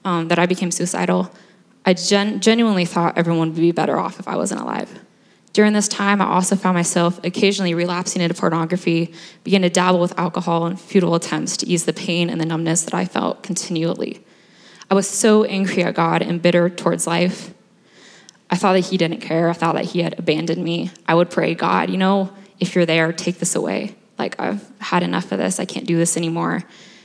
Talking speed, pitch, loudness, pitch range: 210 wpm, 175 Hz, -19 LUFS, 170-195 Hz